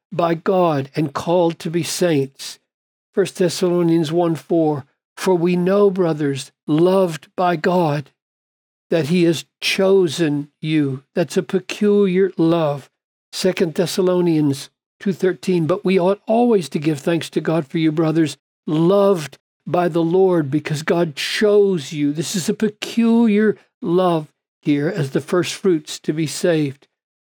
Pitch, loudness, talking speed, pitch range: 170 Hz, -18 LUFS, 145 wpm, 155-190 Hz